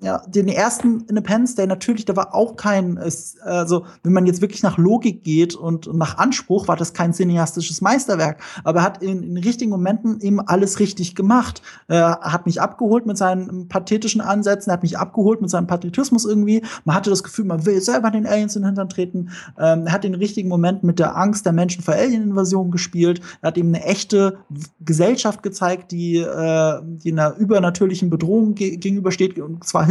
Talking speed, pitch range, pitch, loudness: 190 wpm, 175-205 Hz, 190 Hz, -19 LUFS